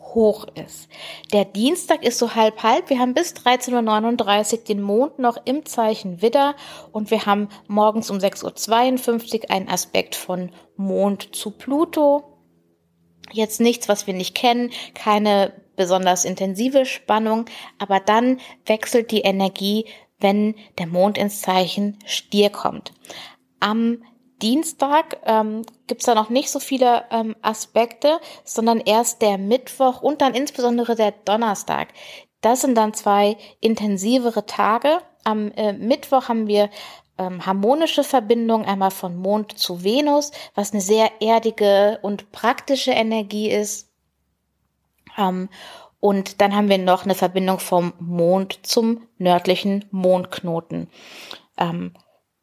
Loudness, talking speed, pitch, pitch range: -20 LUFS, 135 wpm, 215 Hz, 195-240 Hz